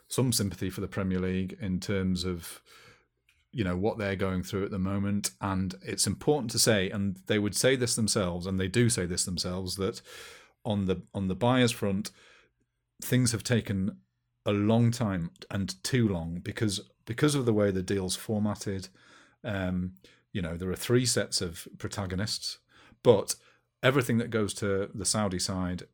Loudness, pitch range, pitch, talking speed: -29 LUFS, 95-110 Hz, 100 Hz, 175 wpm